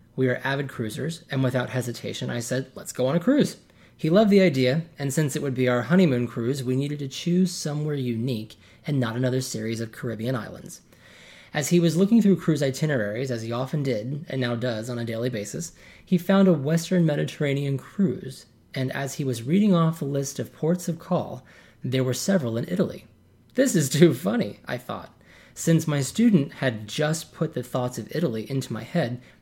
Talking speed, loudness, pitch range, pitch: 200 wpm, -25 LUFS, 125-165 Hz, 140 Hz